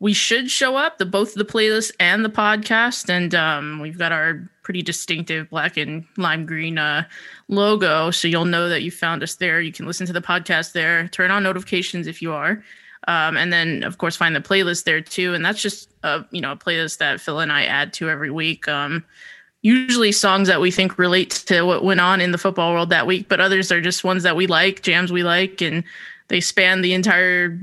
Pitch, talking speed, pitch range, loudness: 180 Hz, 225 wpm, 165-195 Hz, -18 LUFS